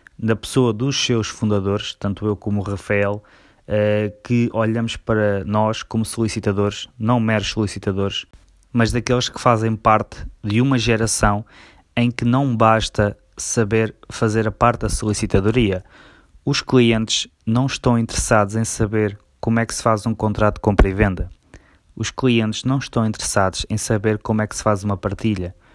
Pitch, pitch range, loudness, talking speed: 110 Hz, 100-115 Hz, -20 LUFS, 165 wpm